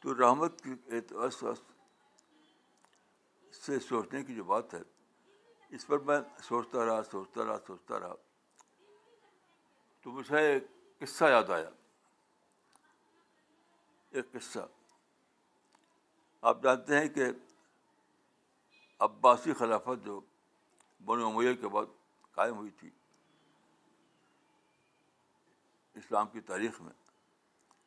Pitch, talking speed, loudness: 145 Hz, 95 wpm, -32 LUFS